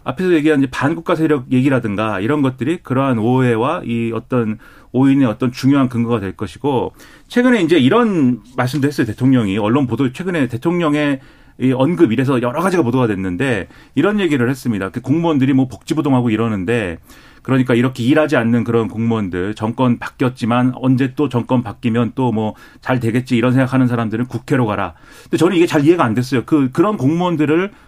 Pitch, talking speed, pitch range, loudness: 130 Hz, 420 characters per minute, 115-145 Hz, -16 LUFS